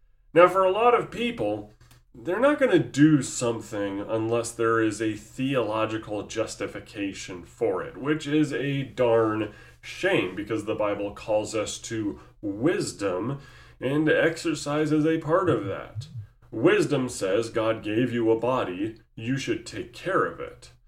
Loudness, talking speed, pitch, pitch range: -25 LUFS, 150 wpm, 115 Hz, 110-150 Hz